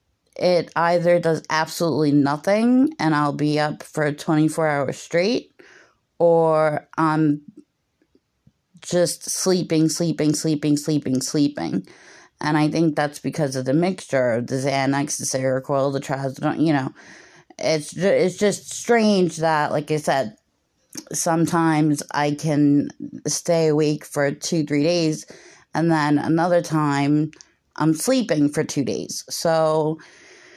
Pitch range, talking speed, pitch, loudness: 145-170 Hz, 130 wpm, 155 Hz, -21 LUFS